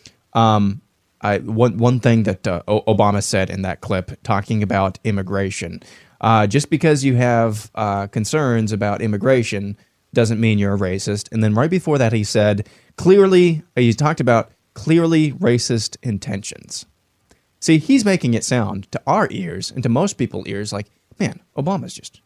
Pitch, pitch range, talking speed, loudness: 110 Hz, 100-125 Hz, 165 wpm, -18 LUFS